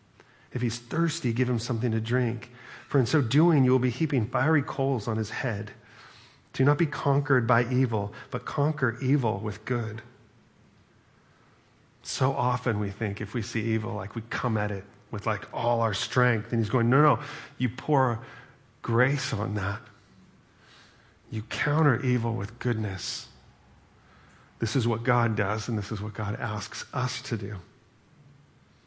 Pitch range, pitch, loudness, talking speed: 110-130 Hz, 120 Hz, -27 LUFS, 165 wpm